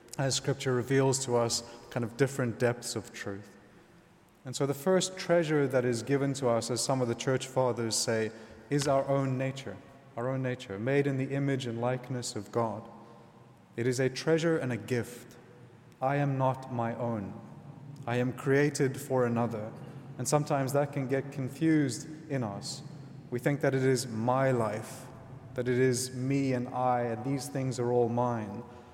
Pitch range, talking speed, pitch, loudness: 120-140 Hz, 180 wpm, 130 Hz, -31 LUFS